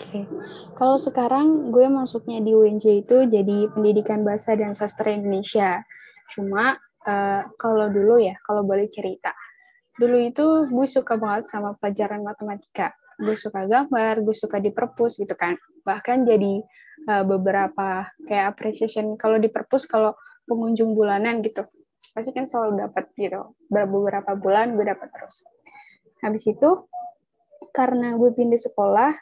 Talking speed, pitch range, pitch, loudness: 140 wpm, 205-250 Hz, 220 Hz, -22 LUFS